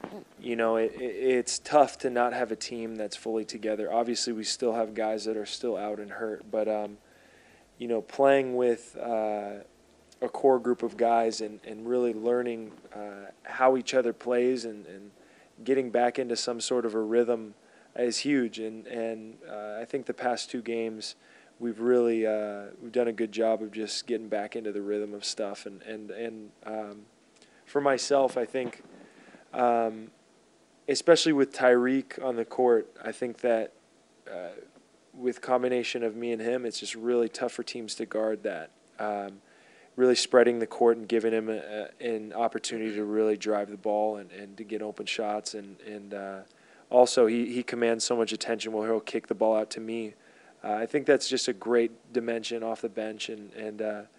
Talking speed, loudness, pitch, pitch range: 190 wpm, -28 LUFS, 115 Hz, 110-120 Hz